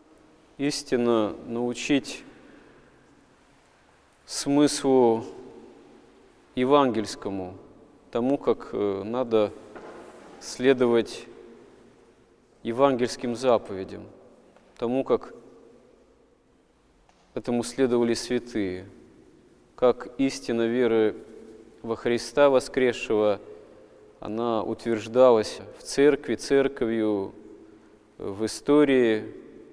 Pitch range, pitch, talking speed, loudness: 110-135 Hz, 120 Hz, 55 wpm, -25 LUFS